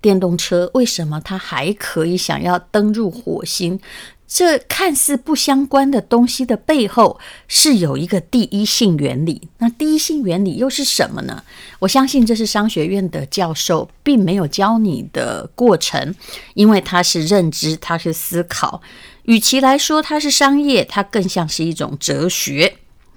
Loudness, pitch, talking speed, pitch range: -16 LUFS, 205 Hz, 240 characters per minute, 175-260 Hz